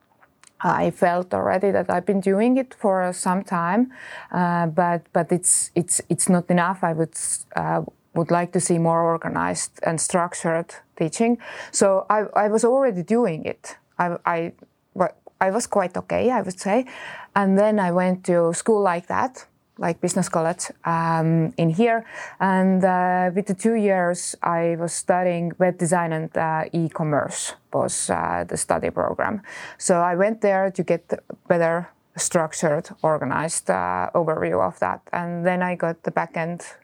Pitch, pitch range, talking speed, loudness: 180 Hz, 165-200 Hz, 165 wpm, -22 LUFS